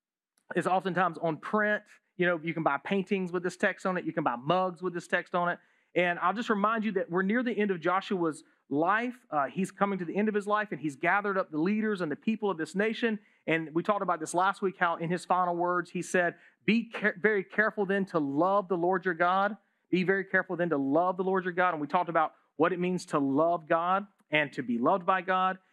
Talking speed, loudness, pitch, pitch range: 255 wpm, -29 LUFS, 185 Hz, 175-200 Hz